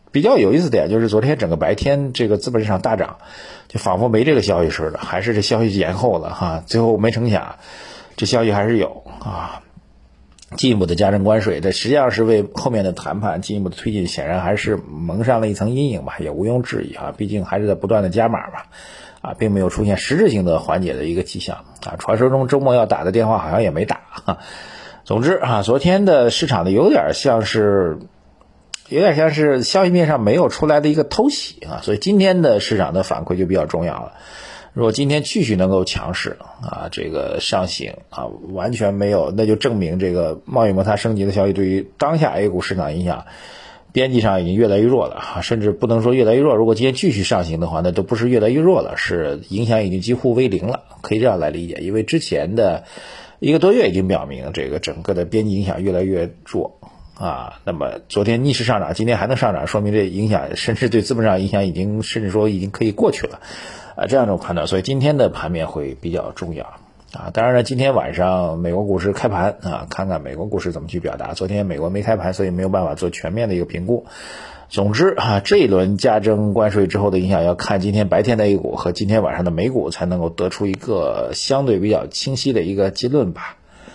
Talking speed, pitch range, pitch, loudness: 340 characters per minute, 95-115 Hz, 105 Hz, -18 LUFS